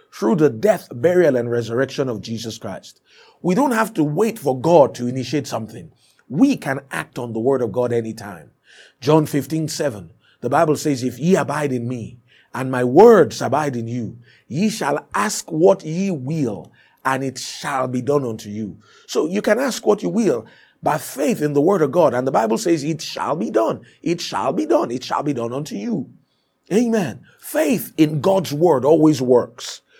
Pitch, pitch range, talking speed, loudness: 140 Hz, 120-165 Hz, 190 wpm, -19 LUFS